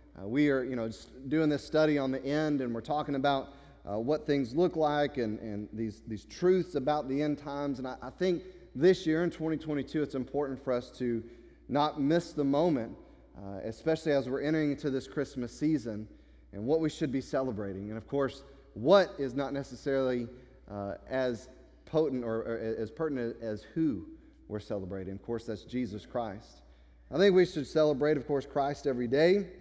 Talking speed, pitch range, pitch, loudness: 195 wpm, 115-150 Hz, 140 Hz, -31 LUFS